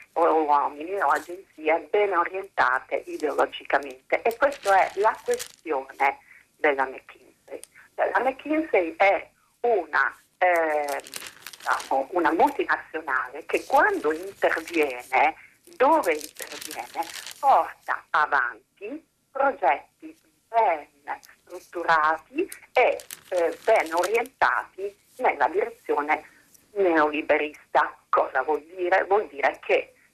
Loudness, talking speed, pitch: -24 LUFS, 90 wpm, 190 Hz